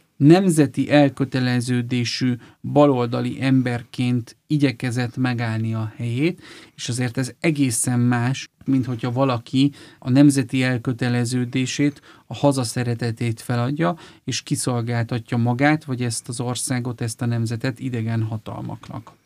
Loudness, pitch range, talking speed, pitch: -21 LUFS, 120-140 Hz, 105 wpm, 125 Hz